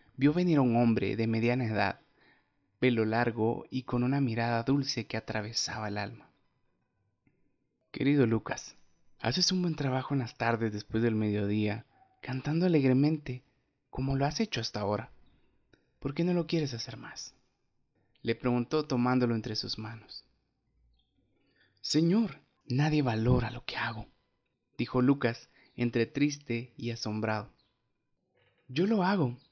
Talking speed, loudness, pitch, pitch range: 135 wpm, -30 LUFS, 125 Hz, 115-140 Hz